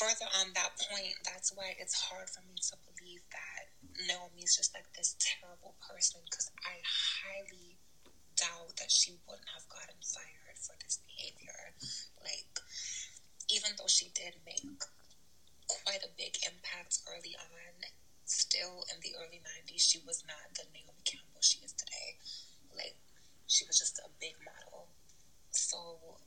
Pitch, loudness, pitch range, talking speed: 180 Hz, -35 LUFS, 175-195 Hz, 150 wpm